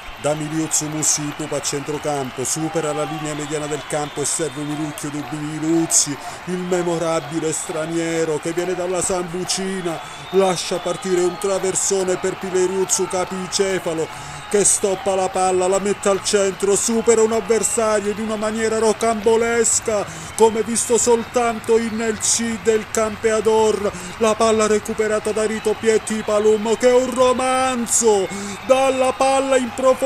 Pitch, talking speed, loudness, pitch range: 190 Hz, 130 wpm, -19 LUFS, 165-220 Hz